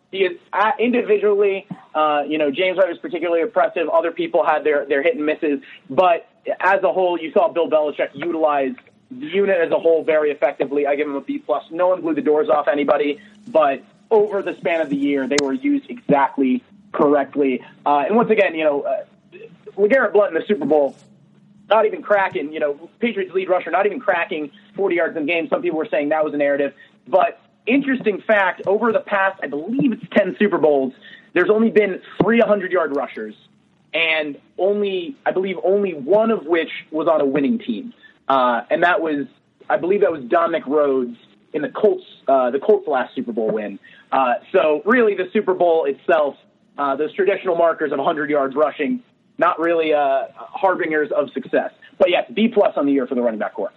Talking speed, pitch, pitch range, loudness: 200 wpm, 175 Hz, 150-210 Hz, -19 LUFS